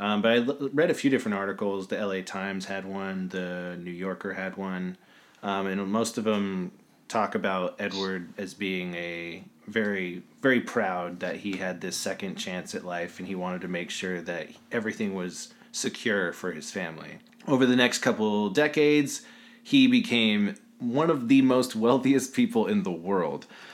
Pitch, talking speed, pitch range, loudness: 100 Hz, 175 wpm, 95-135 Hz, -27 LUFS